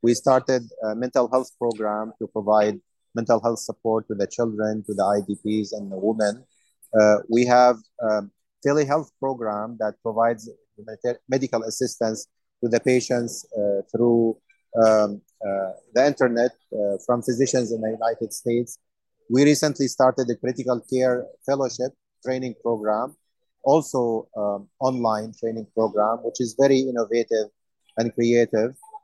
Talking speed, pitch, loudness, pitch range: 135 wpm, 115 Hz, -23 LUFS, 110-125 Hz